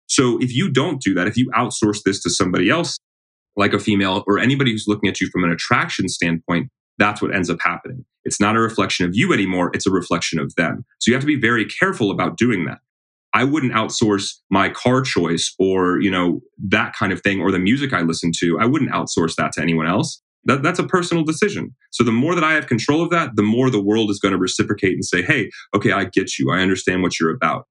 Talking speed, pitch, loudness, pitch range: 245 wpm, 100 Hz, -18 LUFS, 90-120 Hz